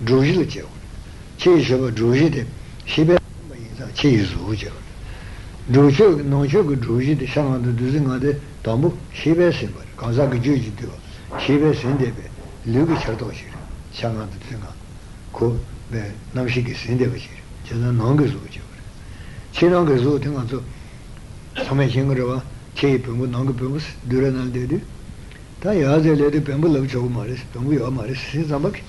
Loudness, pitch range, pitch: -20 LUFS, 115-140 Hz, 125 Hz